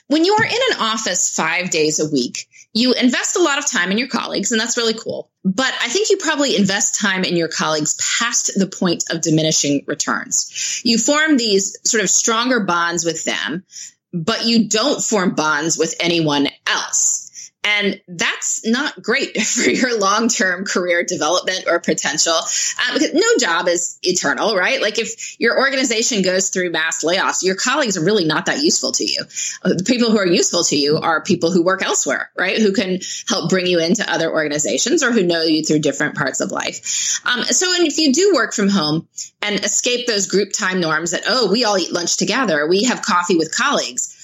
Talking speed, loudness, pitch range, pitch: 200 wpm, -17 LUFS, 170-235 Hz, 200 Hz